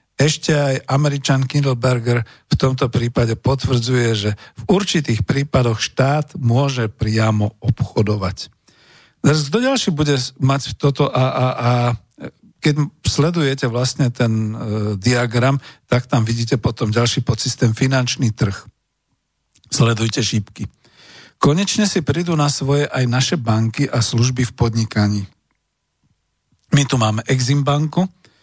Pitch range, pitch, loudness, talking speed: 115-140 Hz, 125 Hz, -18 LUFS, 120 wpm